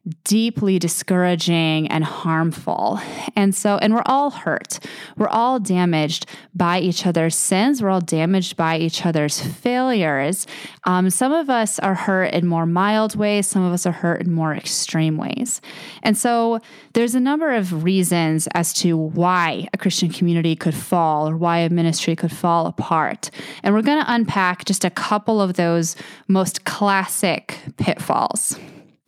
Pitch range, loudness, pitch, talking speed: 165-210 Hz, -19 LUFS, 180 Hz, 160 wpm